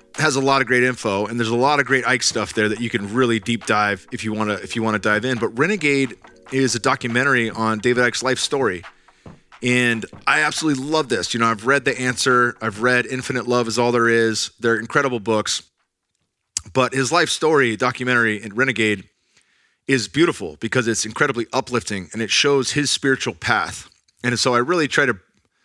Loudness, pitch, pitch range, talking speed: -19 LUFS, 120 Hz, 115-130 Hz, 205 wpm